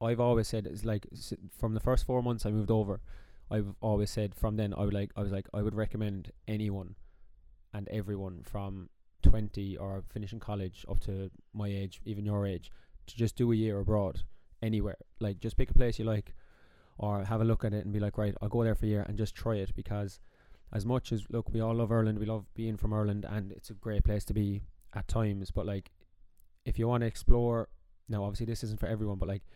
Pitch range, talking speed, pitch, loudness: 100-110 Hz, 235 wpm, 105 Hz, -34 LUFS